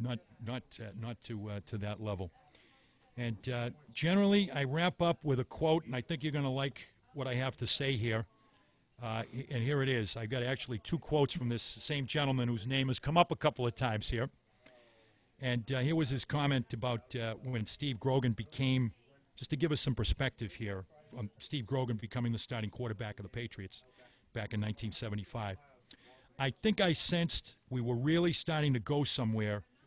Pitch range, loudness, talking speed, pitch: 115-135 Hz, -35 LUFS, 200 wpm, 125 Hz